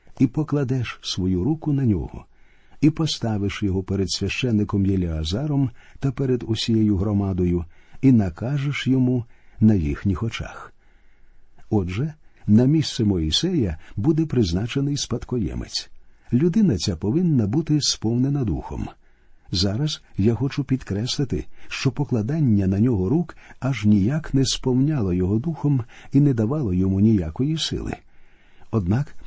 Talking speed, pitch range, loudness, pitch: 115 wpm, 100-140 Hz, -22 LUFS, 115 Hz